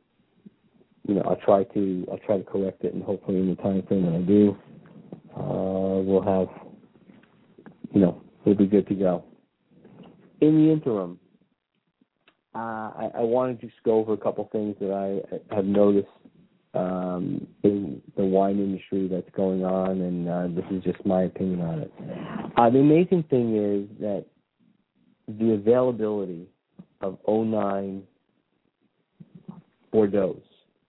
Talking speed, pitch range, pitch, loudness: 150 wpm, 95-110 Hz, 100 Hz, -25 LUFS